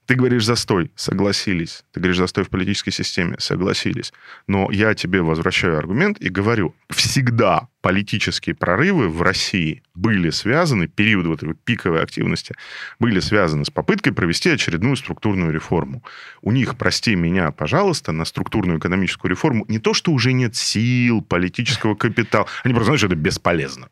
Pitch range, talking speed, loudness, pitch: 90-120 Hz, 155 wpm, -19 LUFS, 100 Hz